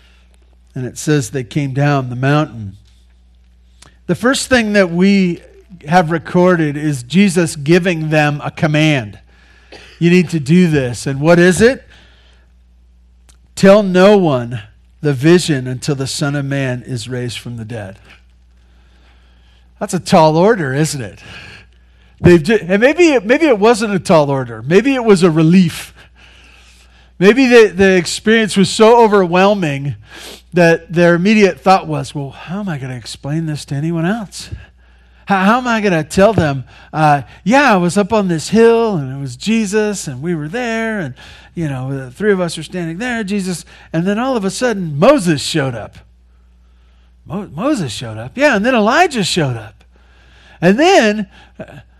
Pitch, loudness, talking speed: 155 Hz, -13 LUFS, 170 wpm